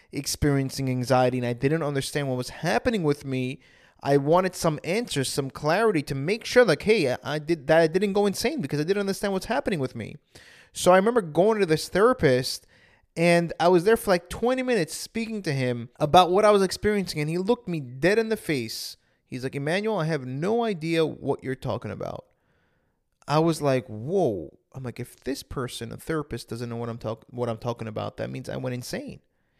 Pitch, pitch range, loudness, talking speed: 155 Hz, 130-190 Hz, -25 LUFS, 215 wpm